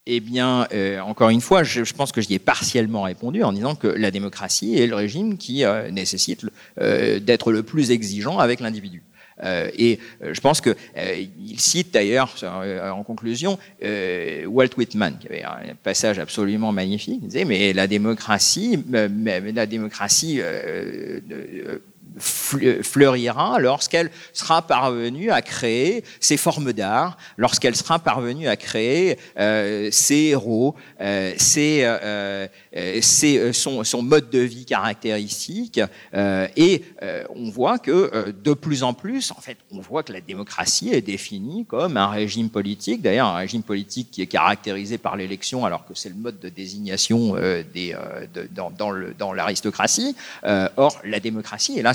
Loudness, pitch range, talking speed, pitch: -21 LUFS, 105-145 Hz, 155 wpm, 115 Hz